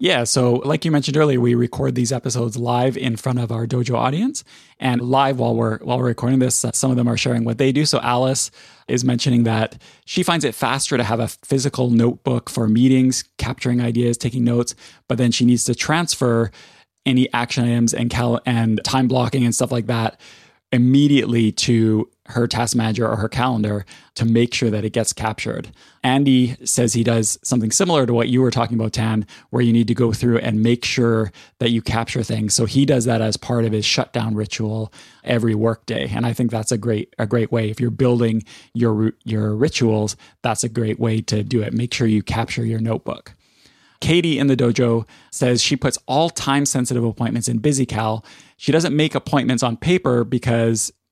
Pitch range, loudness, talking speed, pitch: 115-130 Hz, -19 LUFS, 205 wpm, 120 Hz